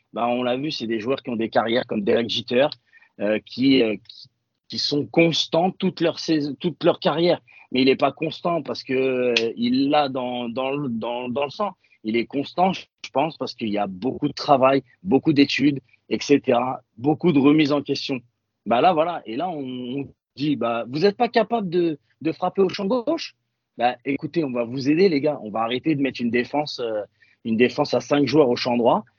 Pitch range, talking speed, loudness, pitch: 120-160 Hz, 220 wpm, -22 LUFS, 140 Hz